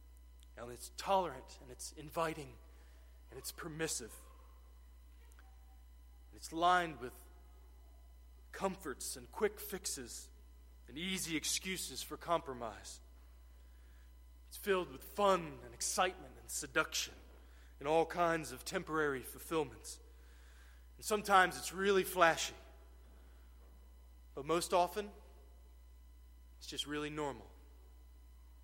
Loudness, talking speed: -37 LUFS, 100 wpm